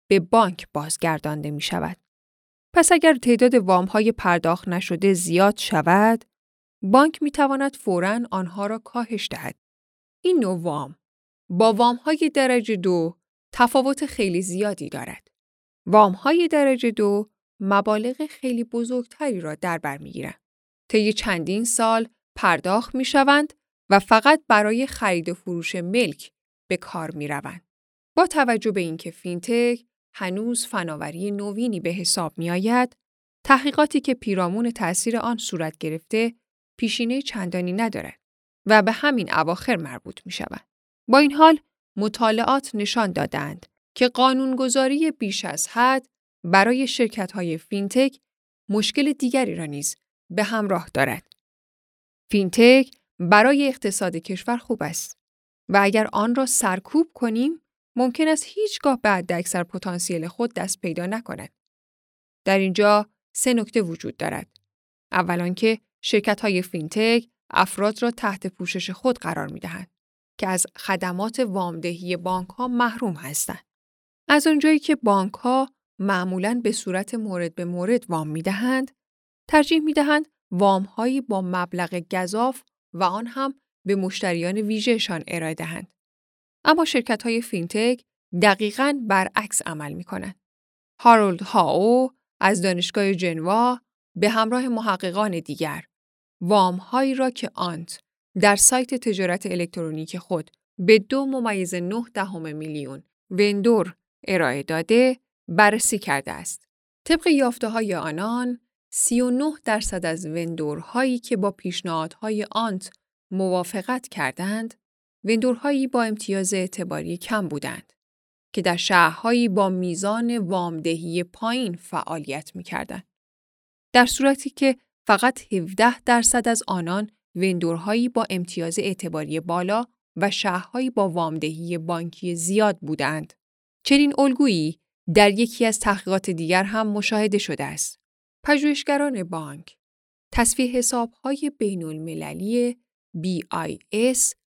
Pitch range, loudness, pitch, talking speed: 180-245 Hz, -22 LUFS, 210 Hz, 125 wpm